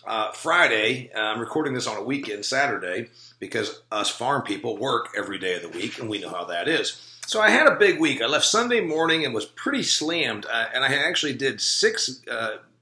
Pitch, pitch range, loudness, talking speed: 140 Hz, 125-205 Hz, -23 LUFS, 220 wpm